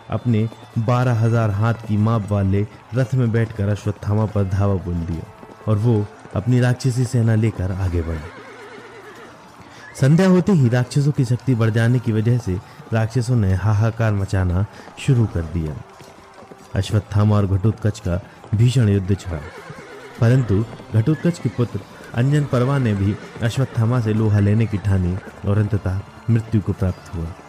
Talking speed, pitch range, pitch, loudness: 150 wpm, 100-120 Hz, 110 Hz, -20 LUFS